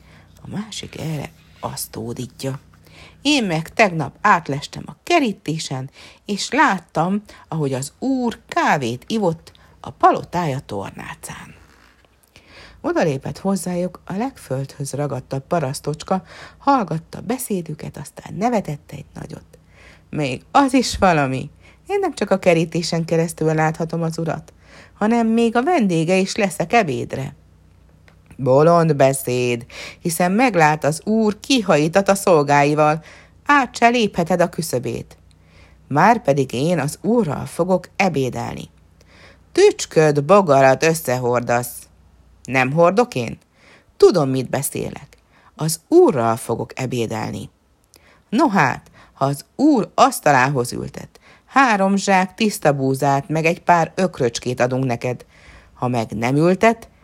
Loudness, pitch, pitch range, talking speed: -19 LUFS, 155 Hz, 130-195 Hz, 115 wpm